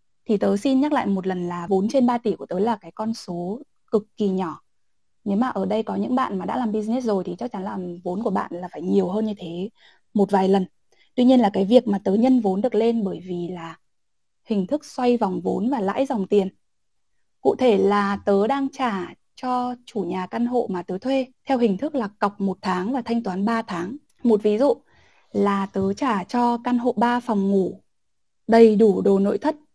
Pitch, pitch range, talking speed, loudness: 205 Hz, 190-245 Hz, 230 wpm, -22 LUFS